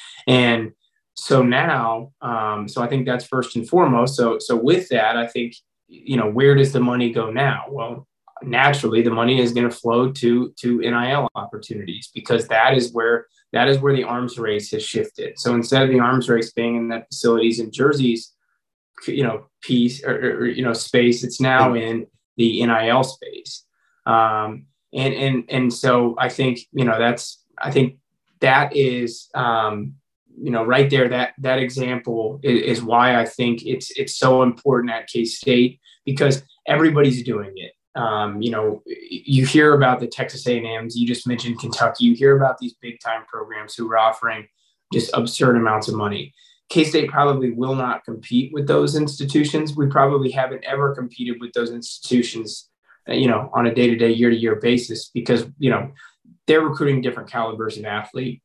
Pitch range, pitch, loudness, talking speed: 115-135 Hz, 125 Hz, -19 LUFS, 185 wpm